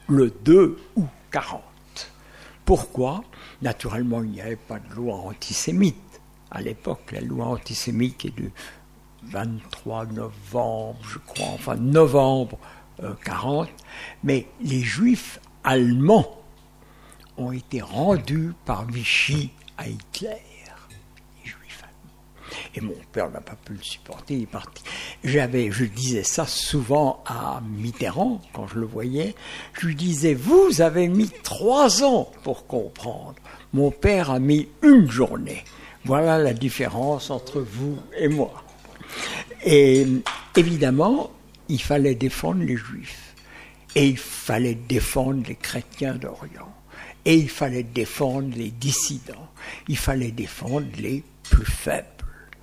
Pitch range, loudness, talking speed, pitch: 120-150 Hz, -22 LUFS, 125 wpm, 135 Hz